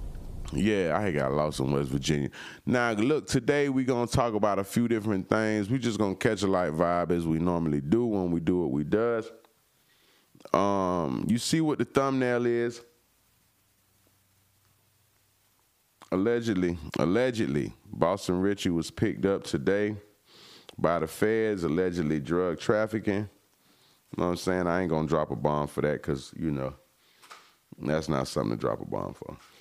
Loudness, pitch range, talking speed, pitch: -28 LUFS, 80-110 Hz, 170 wpm, 95 Hz